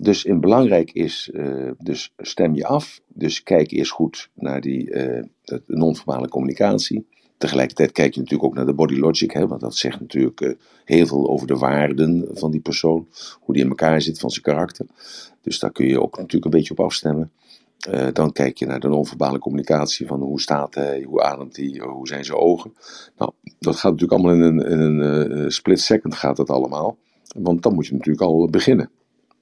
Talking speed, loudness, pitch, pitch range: 205 wpm, -20 LUFS, 75 Hz, 70-80 Hz